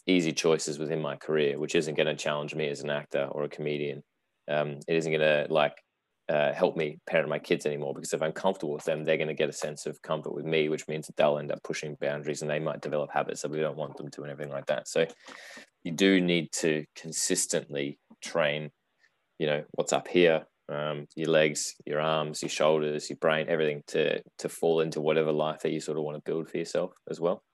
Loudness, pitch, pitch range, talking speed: -29 LUFS, 75 Hz, 75-80 Hz, 235 wpm